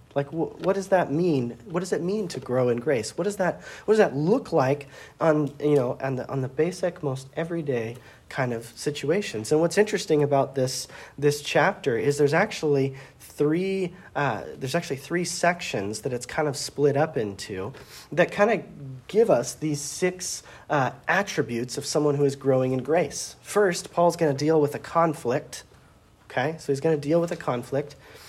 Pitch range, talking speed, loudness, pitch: 135-170 Hz, 190 wpm, -25 LUFS, 145 Hz